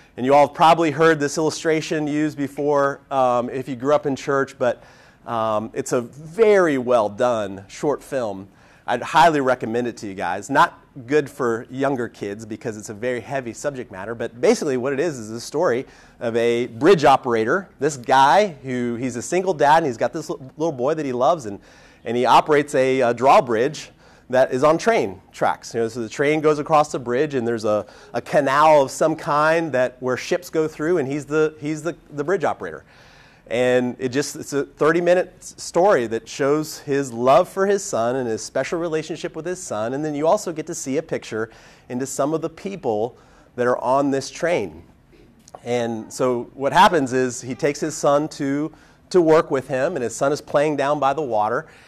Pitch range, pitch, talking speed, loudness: 120-155 Hz, 140 Hz, 205 wpm, -20 LUFS